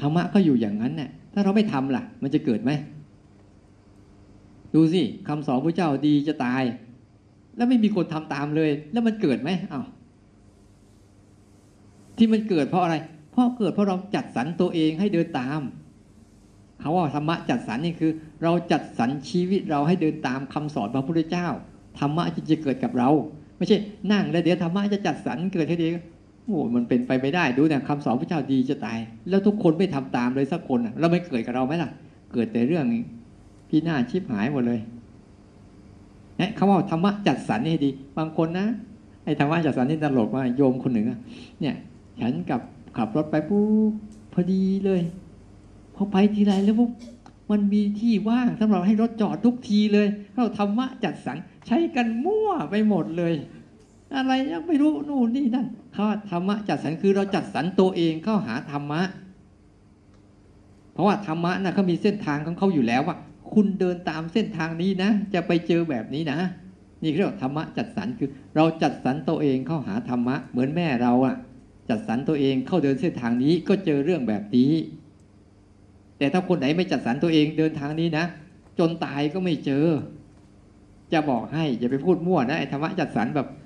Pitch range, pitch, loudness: 130-195 Hz, 160 Hz, -24 LUFS